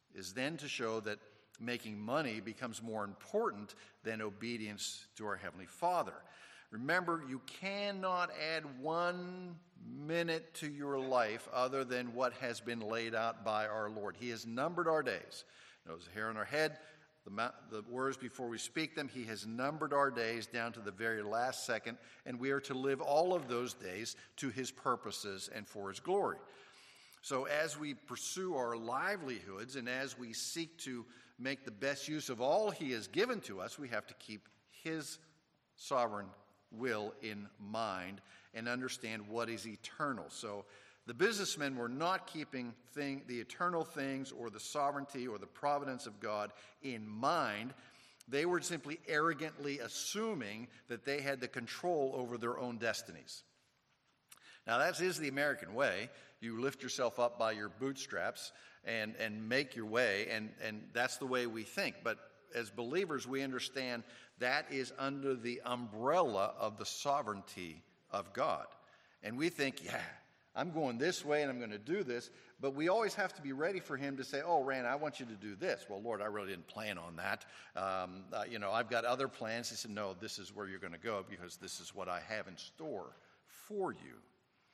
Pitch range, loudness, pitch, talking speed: 110-140 Hz, -39 LUFS, 125 Hz, 185 wpm